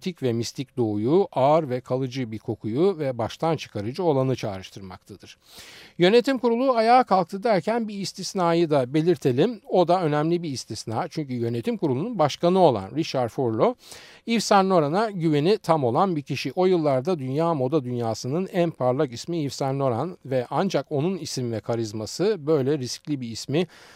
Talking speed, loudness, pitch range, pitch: 160 wpm, -24 LUFS, 125-180 Hz, 150 Hz